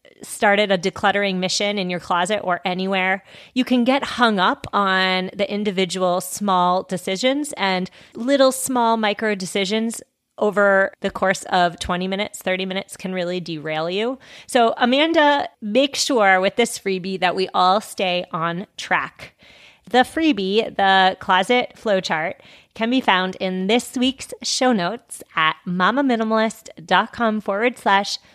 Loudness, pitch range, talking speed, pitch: -20 LUFS, 185-230 Hz, 140 wpm, 195 Hz